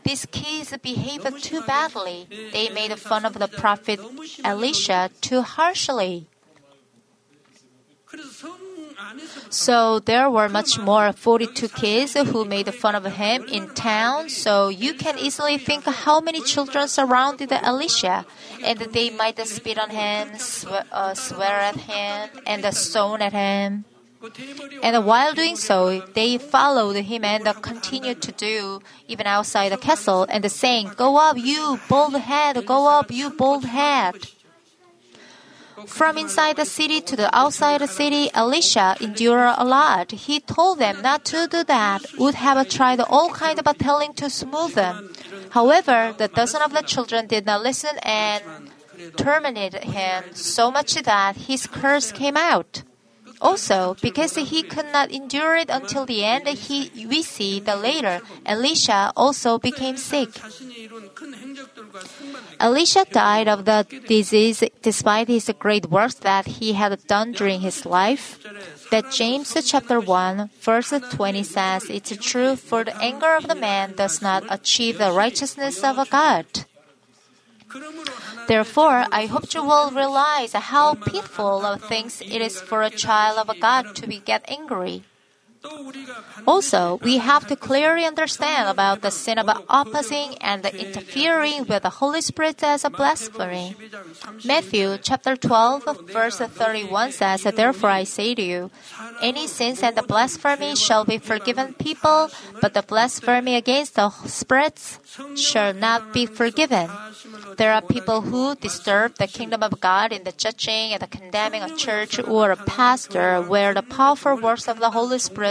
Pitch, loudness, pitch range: 235 Hz, -20 LUFS, 210-280 Hz